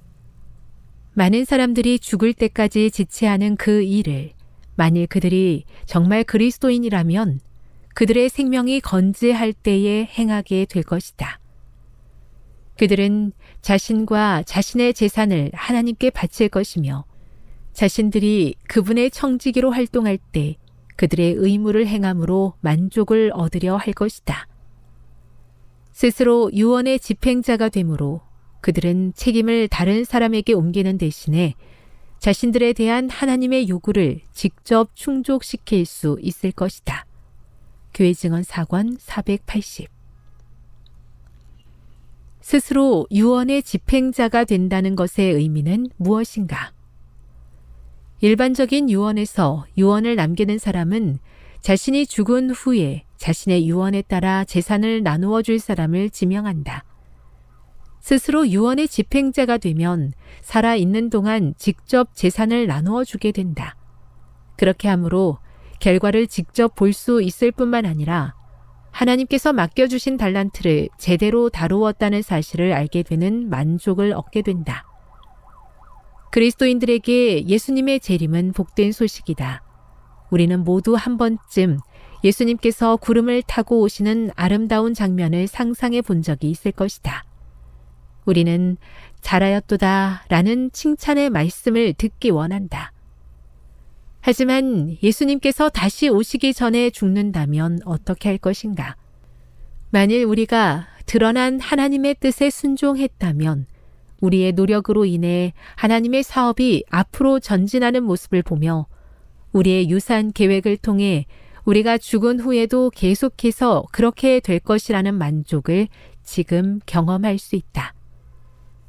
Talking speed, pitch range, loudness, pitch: 260 characters per minute, 170-230 Hz, -19 LUFS, 200 Hz